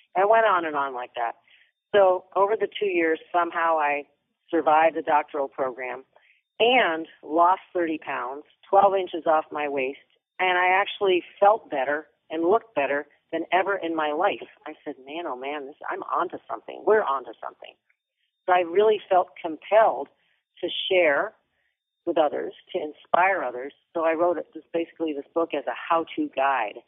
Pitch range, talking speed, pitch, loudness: 150-180 Hz, 165 wpm, 165 Hz, -24 LUFS